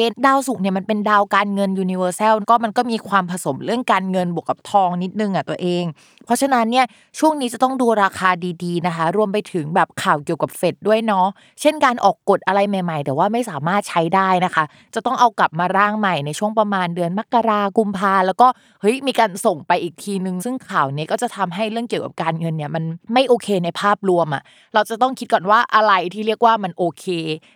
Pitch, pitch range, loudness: 195 Hz, 175-225 Hz, -18 LUFS